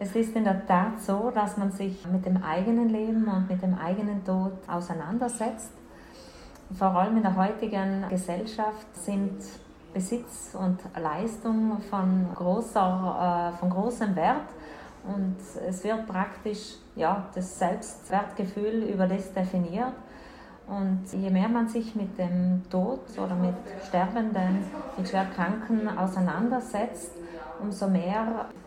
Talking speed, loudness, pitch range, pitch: 125 wpm, -28 LUFS, 185-220 Hz, 195 Hz